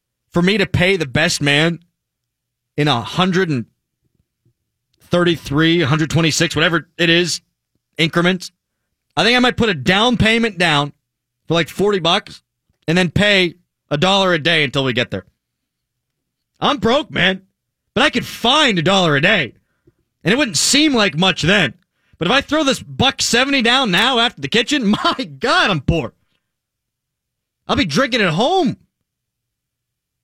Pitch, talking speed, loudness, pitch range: 170 Hz, 165 wpm, -15 LUFS, 140-200 Hz